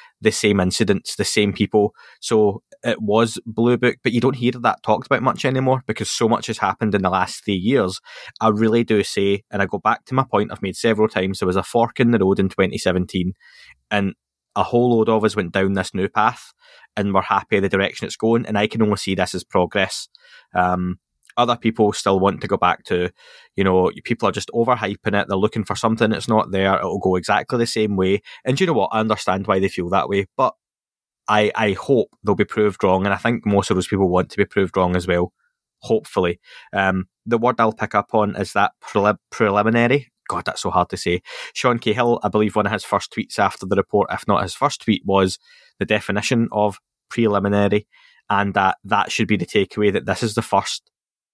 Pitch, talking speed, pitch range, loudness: 105 Hz, 230 wpm, 95-115 Hz, -20 LUFS